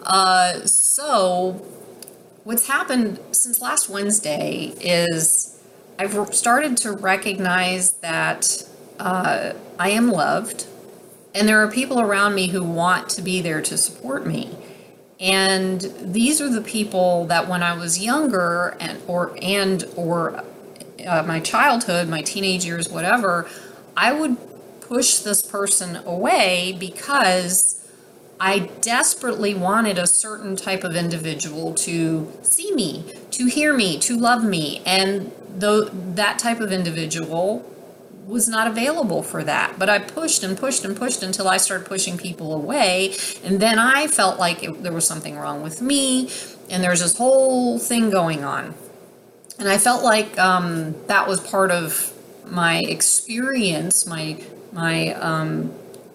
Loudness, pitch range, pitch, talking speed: -19 LUFS, 180-225 Hz, 195 Hz, 140 wpm